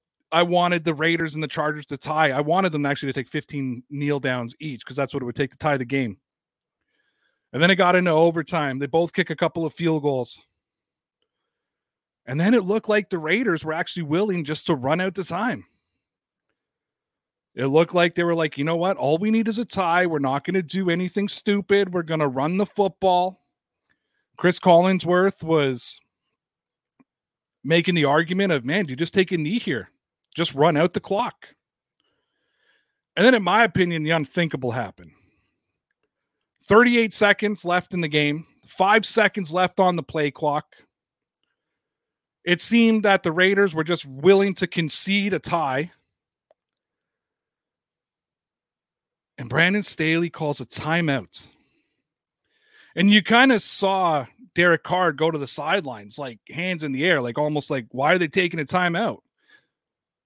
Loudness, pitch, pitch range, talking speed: -21 LUFS, 170 Hz, 150-190 Hz, 170 wpm